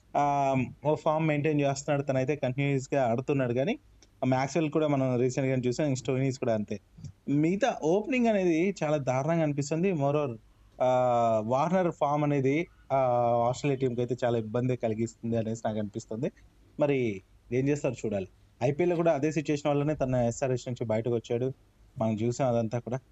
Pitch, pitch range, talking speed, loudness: 130 Hz, 120-150 Hz, 140 wpm, -29 LUFS